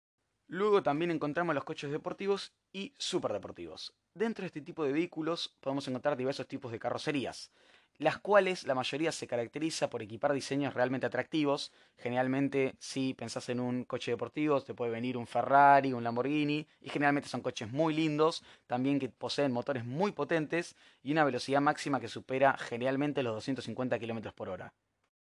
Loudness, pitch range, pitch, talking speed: -33 LUFS, 125-155 Hz, 140 Hz, 165 wpm